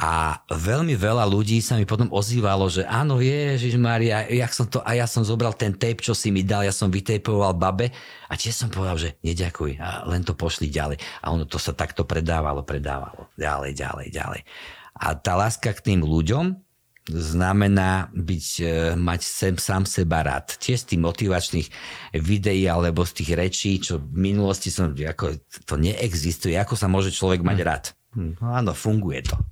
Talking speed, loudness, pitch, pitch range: 180 wpm, -23 LUFS, 95 Hz, 85-110 Hz